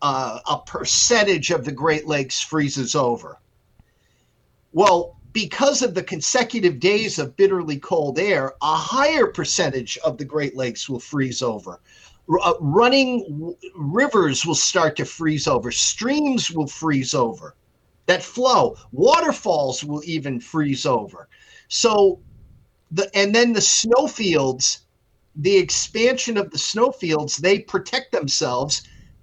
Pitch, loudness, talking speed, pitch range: 165 Hz, -20 LUFS, 130 wpm, 145-215 Hz